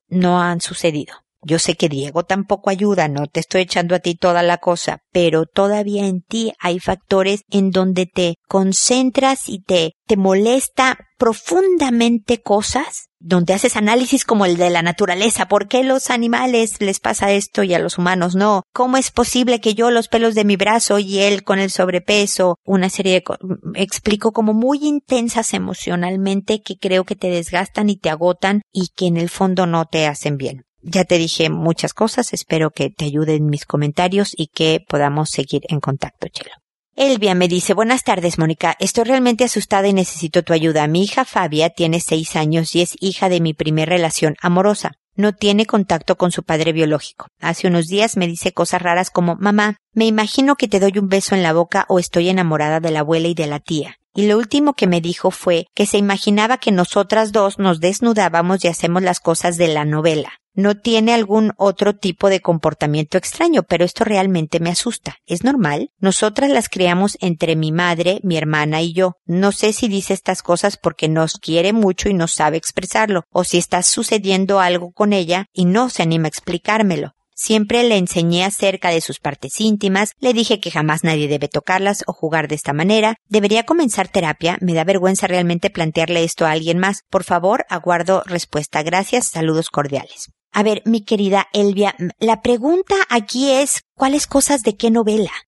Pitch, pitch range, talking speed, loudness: 190 Hz, 170-215 Hz, 190 wpm, -17 LUFS